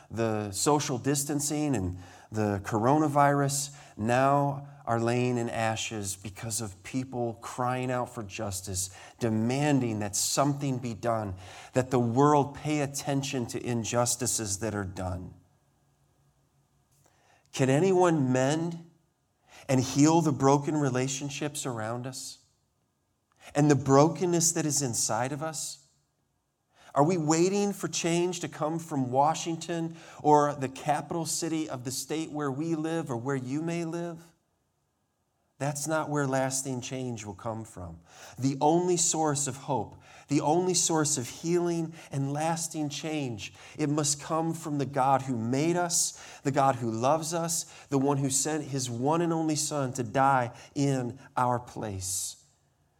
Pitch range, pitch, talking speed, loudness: 120-155 Hz, 140 Hz, 140 wpm, -28 LUFS